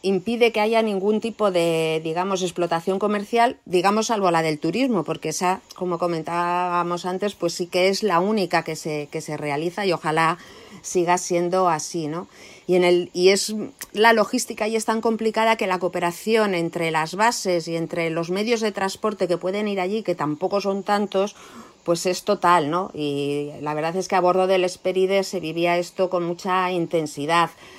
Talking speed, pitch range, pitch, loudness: 185 wpm, 170-200 Hz, 180 Hz, -22 LUFS